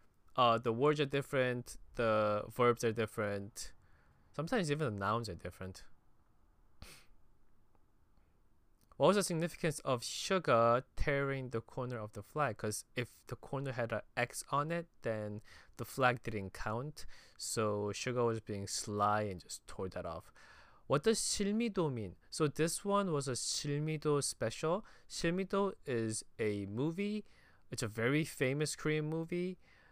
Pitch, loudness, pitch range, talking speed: 125 Hz, -36 LUFS, 105-155 Hz, 145 wpm